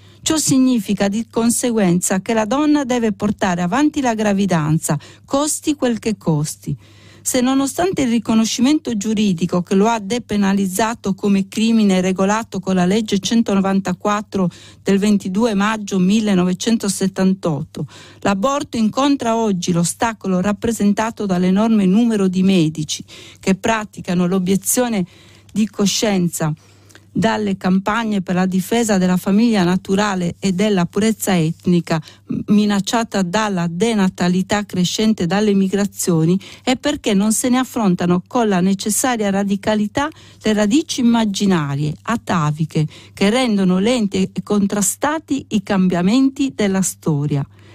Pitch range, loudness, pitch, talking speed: 185-225 Hz, -17 LUFS, 205 Hz, 115 wpm